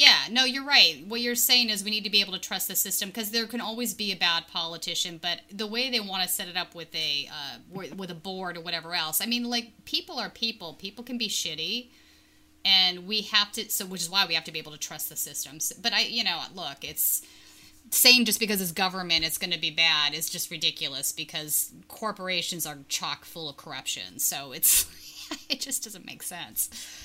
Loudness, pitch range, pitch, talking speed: -25 LUFS, 170-230 Hz, 195 Hz, 230 wpm